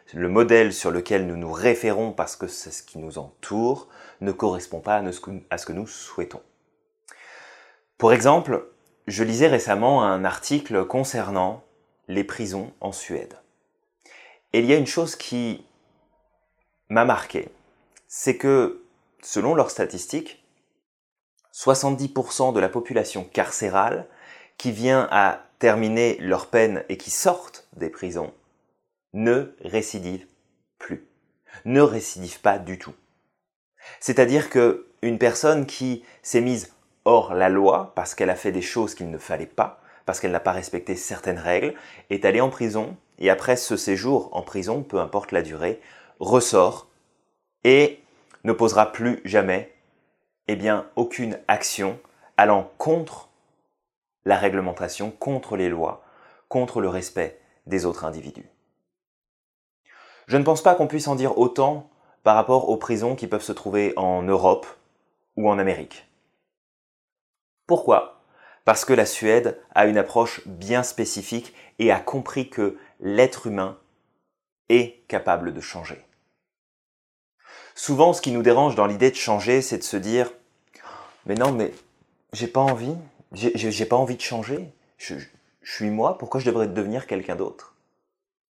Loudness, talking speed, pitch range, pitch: -22 LUFS, 145 wpm, 100-130 Hz, 115 Hz